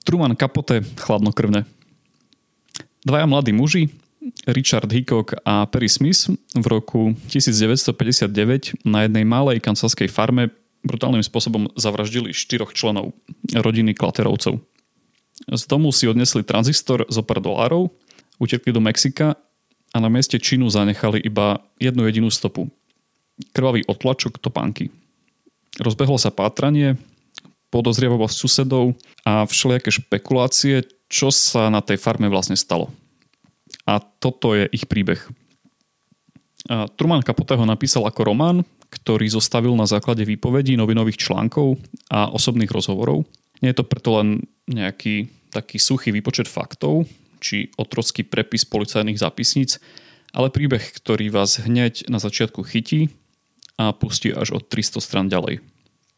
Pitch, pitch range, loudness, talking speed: 120 Hz, 110-130 Hz, -19 LUFS, 125 wpm